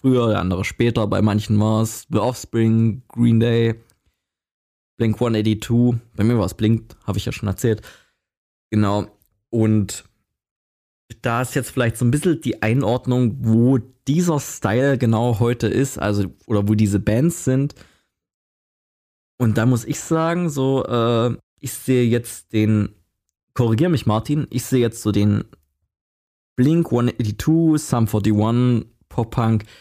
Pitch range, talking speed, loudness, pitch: 105-125 Hz, 145 wpm, -20 LUFS, 115 Hz